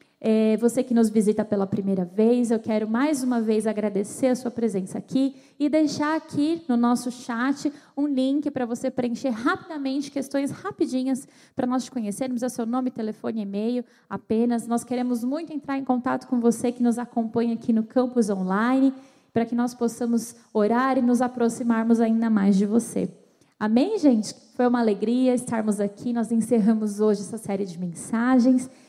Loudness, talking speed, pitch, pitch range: -24 LUFS, 175 wpm, 240 Hz, 225-260 Hz